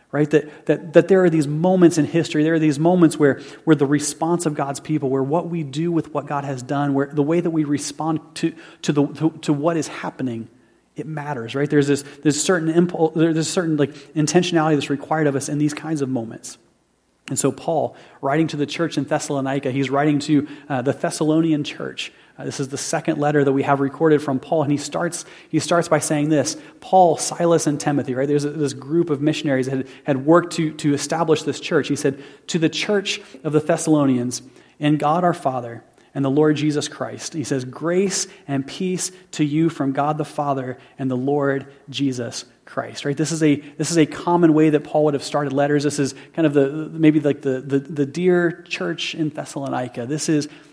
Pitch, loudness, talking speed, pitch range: 150 Hz, -20 LUFS, 220 wpm, 140-160 Hz